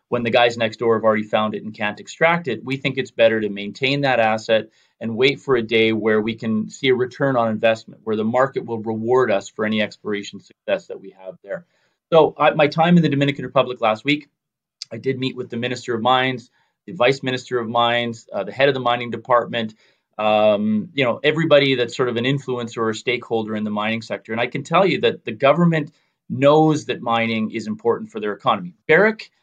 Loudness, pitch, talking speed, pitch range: -19 LUFS, 120 Hz, 225 wpm, 110-140 Hz